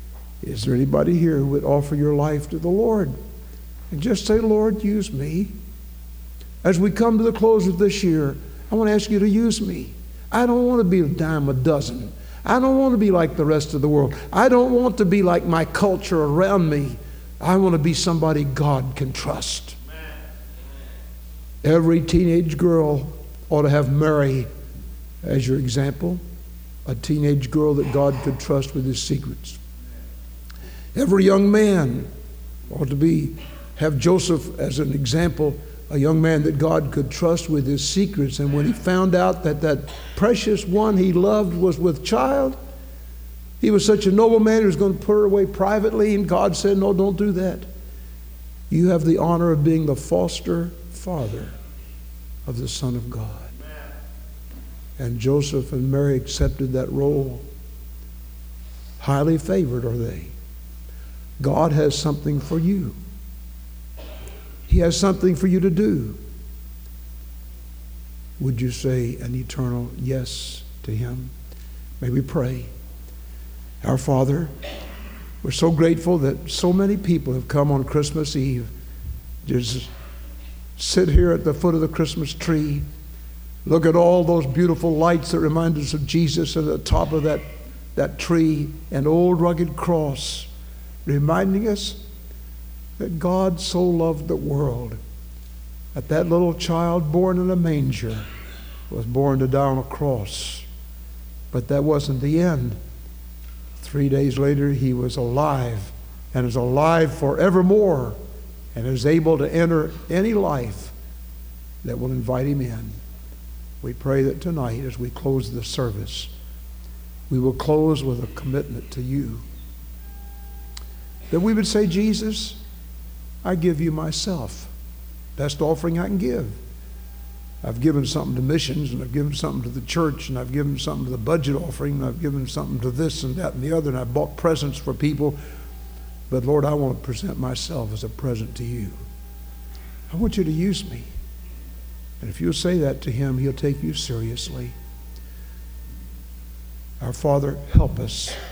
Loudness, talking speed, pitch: -21 LUFS, 160 wpm, 135 Hz